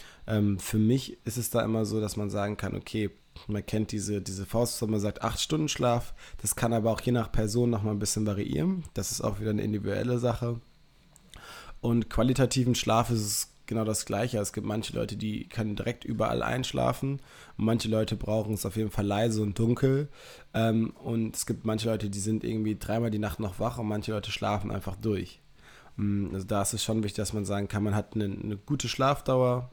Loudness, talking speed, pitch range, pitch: -30 LUFS, 205 wpm, 105-115 Hz, 110 Hz